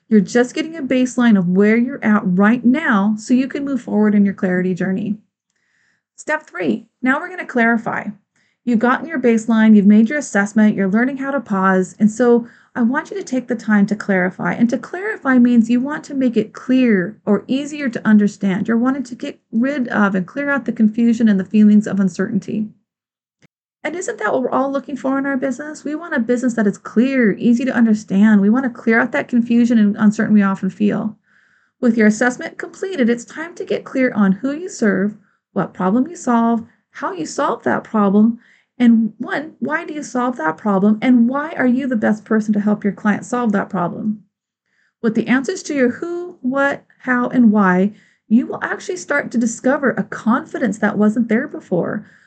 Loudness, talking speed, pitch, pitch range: -17 LUFS, 205 wpm, 235 Hz, 210-265 Hz